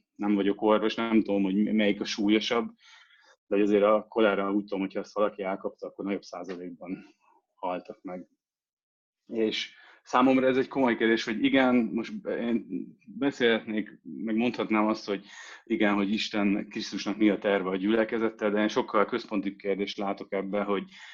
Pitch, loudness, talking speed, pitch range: 105 Hz, -27 LUFS, 160 wpm, 100-115 Hz